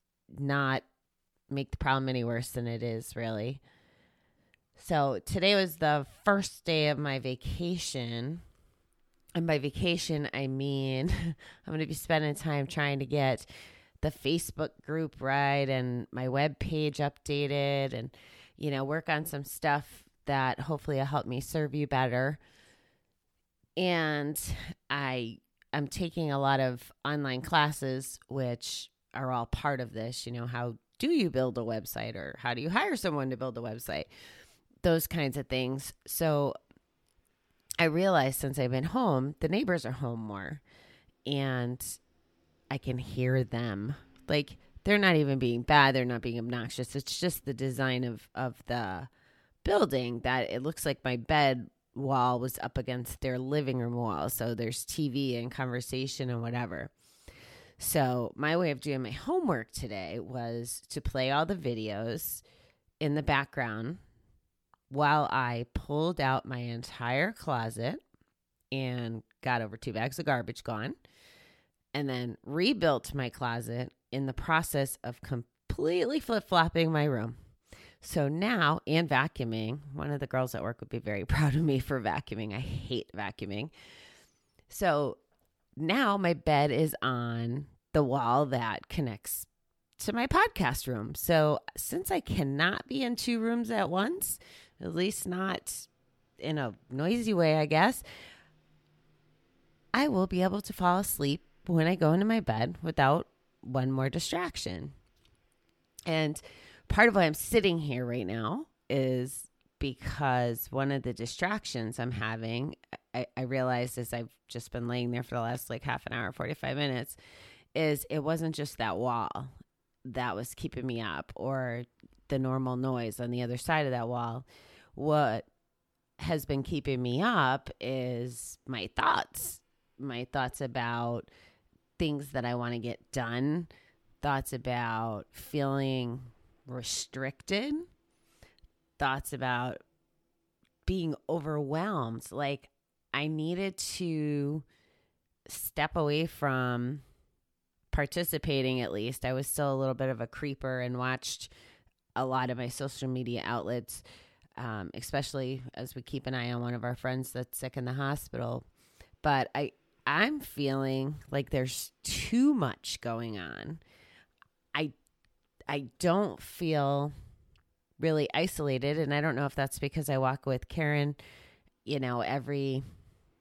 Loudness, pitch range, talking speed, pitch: -32 LUFS, 120-150 Hz, 145 wpm, 135 Hz